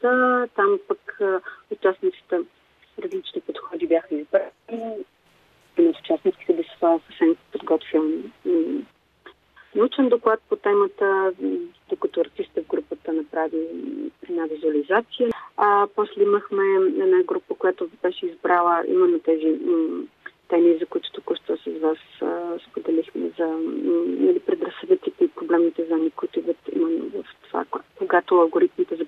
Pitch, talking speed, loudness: 325 Hz, 125 wpm, -23 LUFS